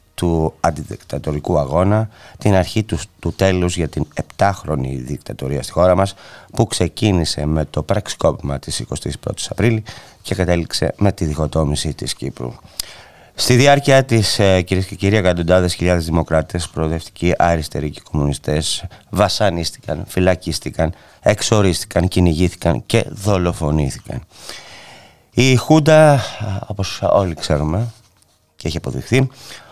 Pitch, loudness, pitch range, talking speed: 90 Hz, -17 LUFS, 80-105 Hz, 115 wpm